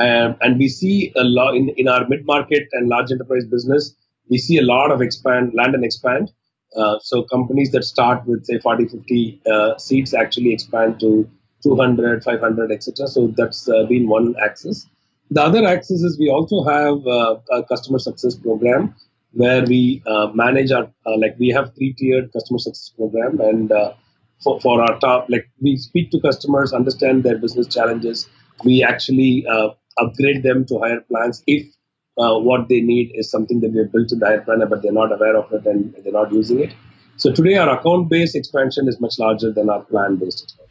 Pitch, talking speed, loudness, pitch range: 125 Hz, 200 wpm, -17 LUFS, 115-135 Hz